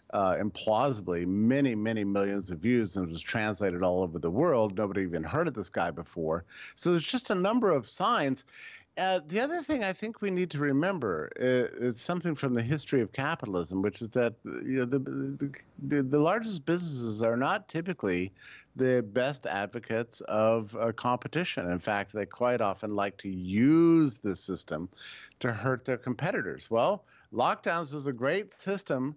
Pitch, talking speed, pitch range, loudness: 125 Hz, 175 wpm, 100-155 Hz, -30 LUFS